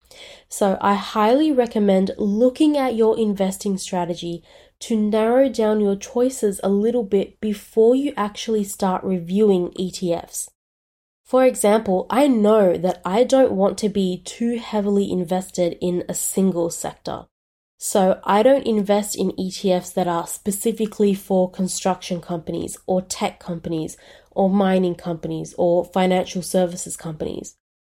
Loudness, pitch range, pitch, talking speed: -20 LUFS, 180-220 Hz, 195 Hz, 135 wpm